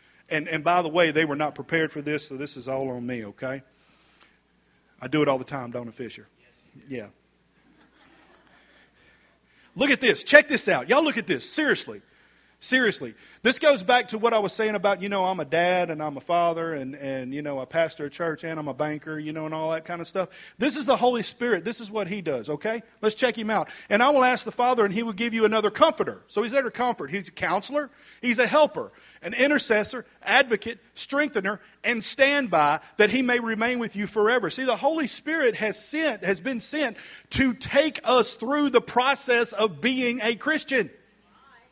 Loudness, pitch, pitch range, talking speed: -24 LUFS, 215 Hz, 160-250 Hz, 215 wpm